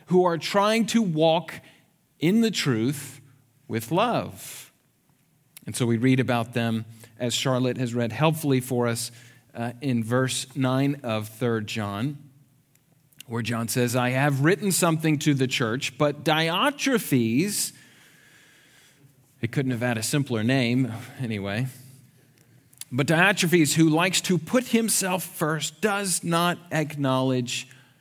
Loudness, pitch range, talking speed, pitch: -24 LUFS, 125-160 Hz, 130 wpm, 135 Hz